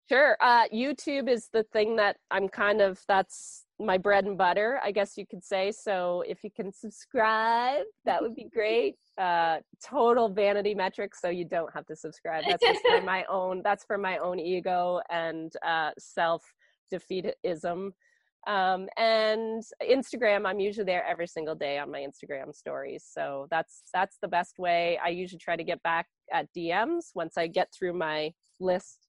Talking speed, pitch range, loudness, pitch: 170 wpm, 175-220 Hz, -28 LUFS, 190 Hz